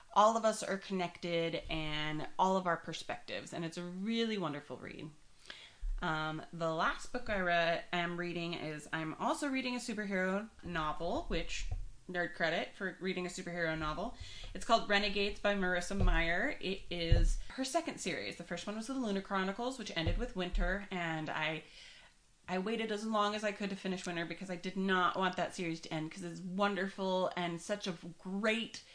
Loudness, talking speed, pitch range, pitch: -36 LUFS, 185 wpm, 165-205 Hz, 180 Hz